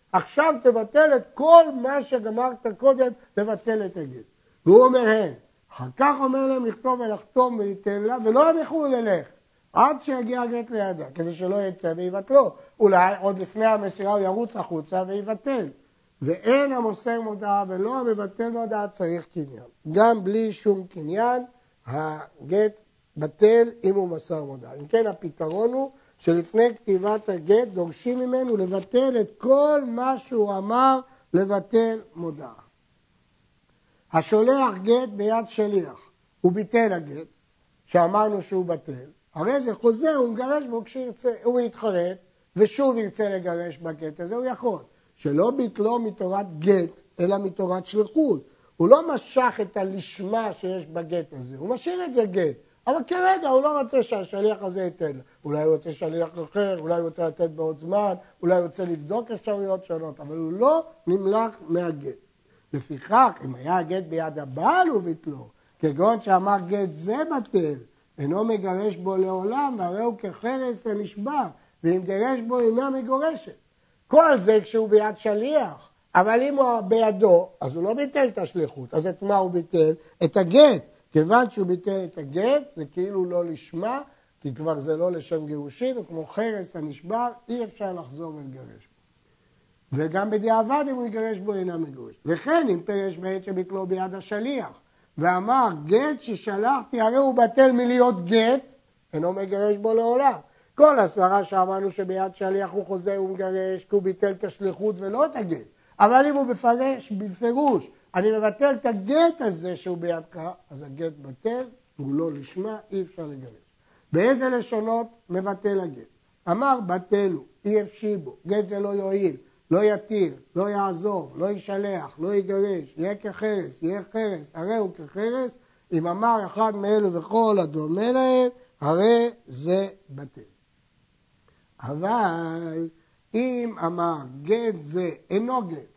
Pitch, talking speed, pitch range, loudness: 205 Hz, 145 wpm, 175-235 Hz, -23 LUFS